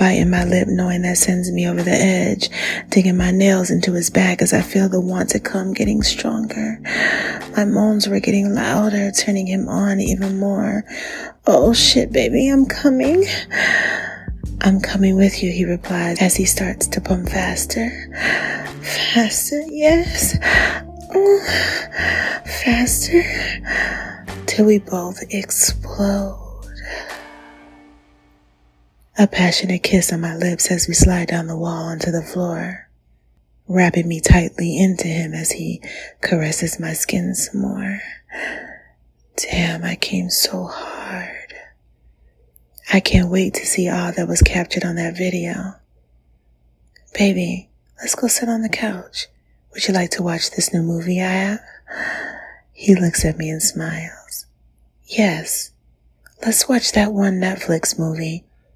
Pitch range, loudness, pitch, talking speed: 165-200 Hz, -18 LUFS, 185 Hz, 135 wpm